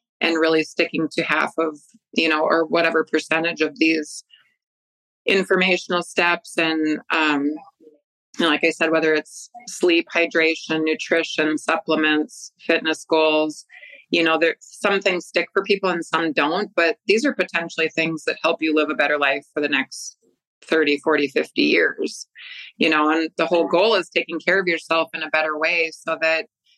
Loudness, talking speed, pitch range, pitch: -20 LUFS, 170 wpm, 155-175 Hz, 160 Hz